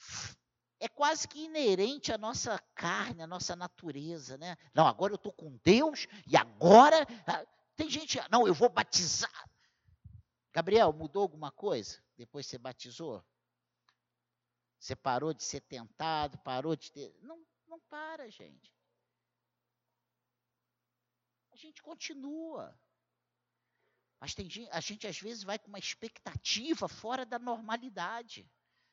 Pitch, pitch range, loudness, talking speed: 200 Hz, 155-260 Hz, -31 LUFS, 125 wpm